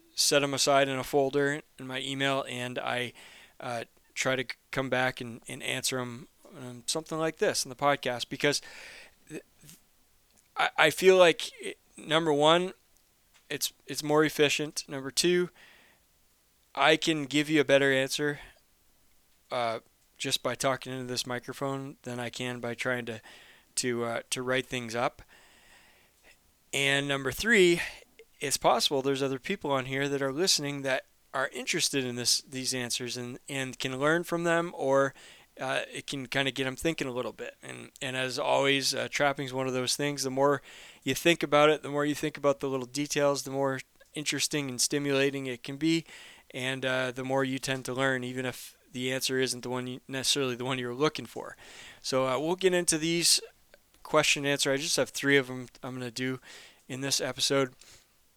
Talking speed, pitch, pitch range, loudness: 190 wpm, 135 Hz, 130-145 Hz, -28 LUFS